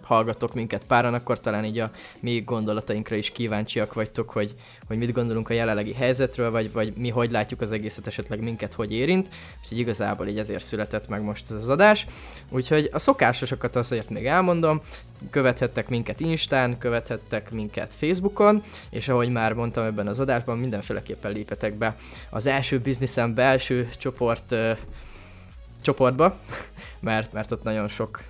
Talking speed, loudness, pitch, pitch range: 155 wpm, -25 LUFS, 115 Hz, 105-125 Hz